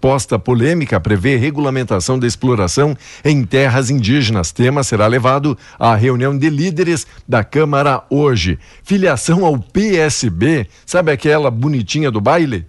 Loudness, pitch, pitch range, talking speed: -14 LUFS, 135 Hz, 120-150 Hz, 130 wpm